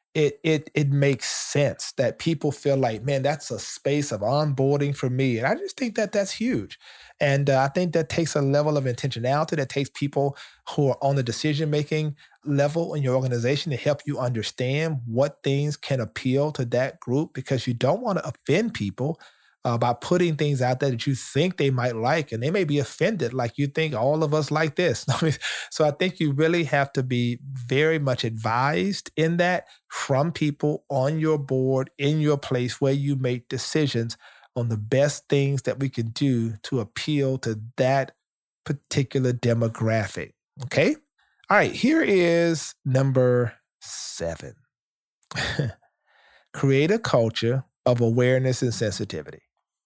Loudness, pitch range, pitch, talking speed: -24 LUFS, 125-155 Hz, 140 Hz, 170 wpm